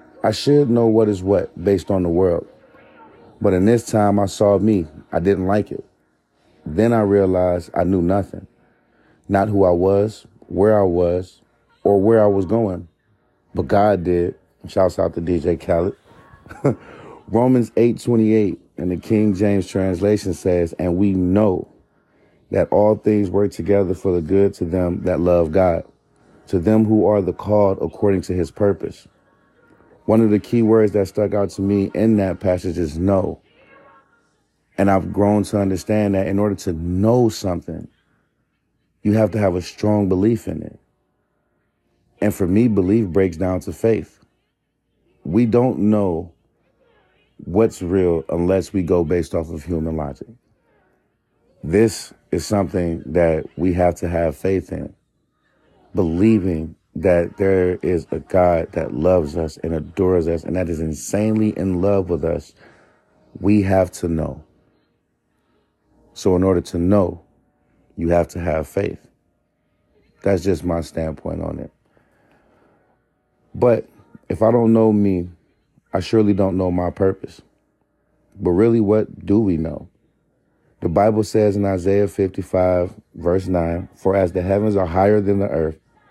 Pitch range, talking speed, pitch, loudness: 90-105 Hz, 155 wpm, 95 Hz, -19 LUFS